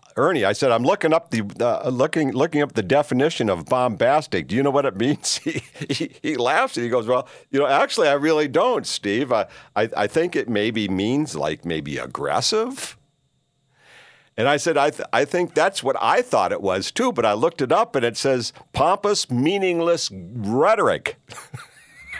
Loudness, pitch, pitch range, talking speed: -21 LUFS, 125 Hz, 110-160 Hz, 190 wpm